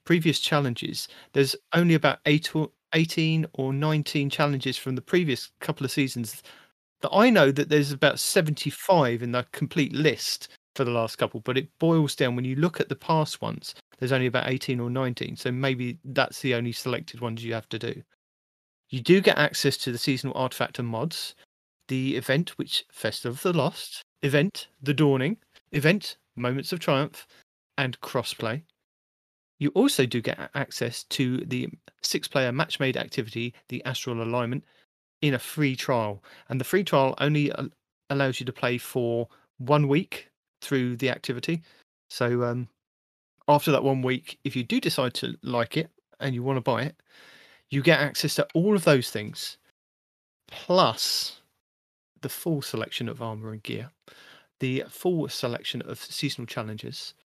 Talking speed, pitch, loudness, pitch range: 170 wpm, 135 Hz, -26 LUFS, 120-150 Hz